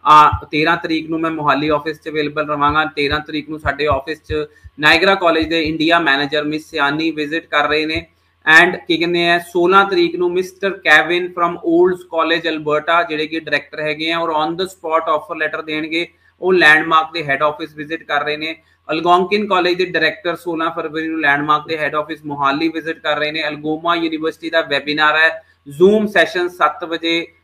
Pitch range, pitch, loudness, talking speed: 150-170 Hz, 160 Hz, -16 LUFS, 190 wpm